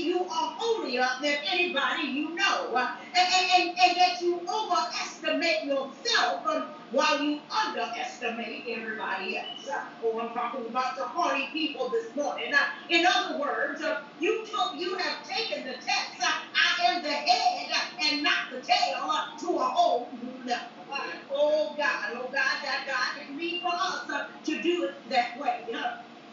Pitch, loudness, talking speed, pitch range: 305 Hz, -28 LUFS, 165 wpm, 265-360 Hz